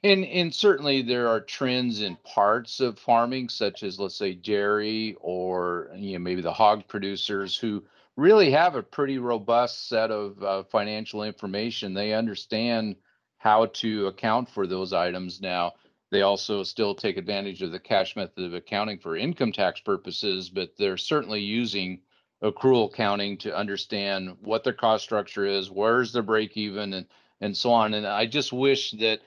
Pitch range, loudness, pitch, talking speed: 100-120 Hz, -26 LUFS, 105 Hz, 170 wpm